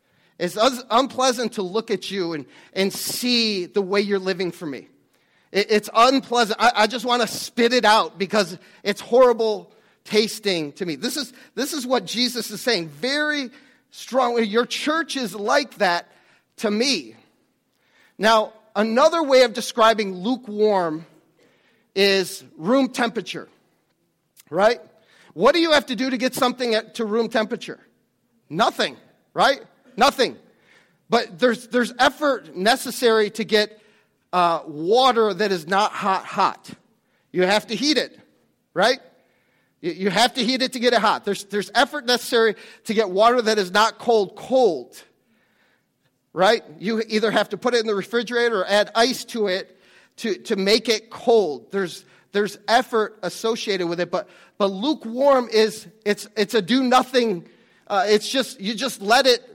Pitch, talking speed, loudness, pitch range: 225 Hz, 160 wpm, -21 LUFS, 200-245 Hz